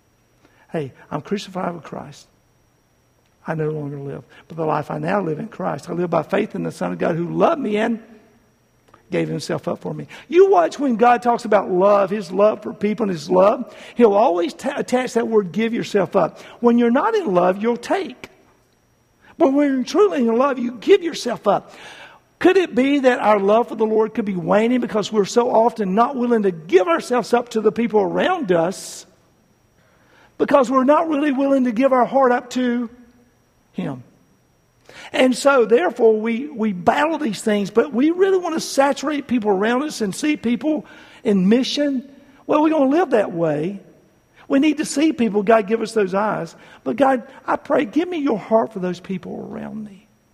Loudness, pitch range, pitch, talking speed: -19 LUFS, 200-275 Hz, 230 Hz, 200 wpm